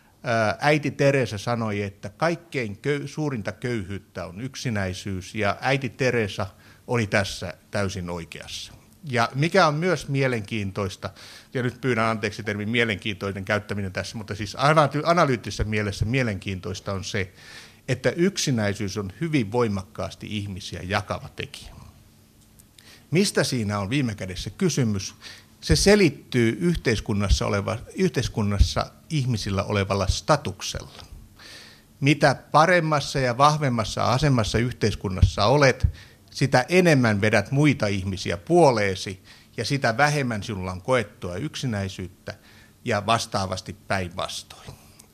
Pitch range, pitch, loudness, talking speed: 100-130 Hz, 110 Hz, -24 LUFS, 110 wpm